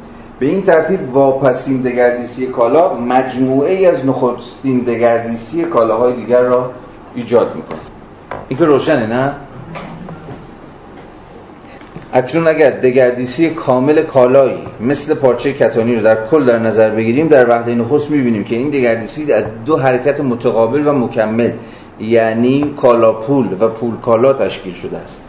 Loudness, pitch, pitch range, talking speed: -13 LUFS, 125 Hz, 115-140 Hz, 135 wpm